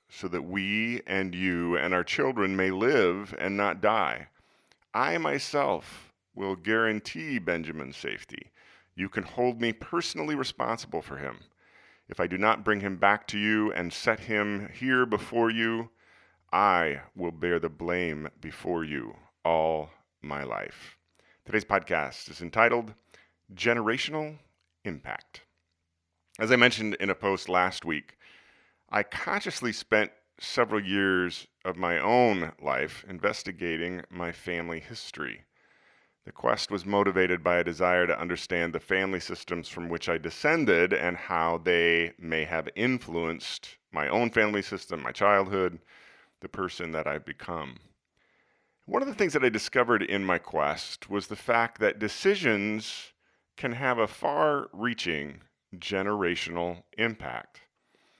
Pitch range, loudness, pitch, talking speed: 85-110 Hz, -28 LUFS, 95 Hz, 140 wpm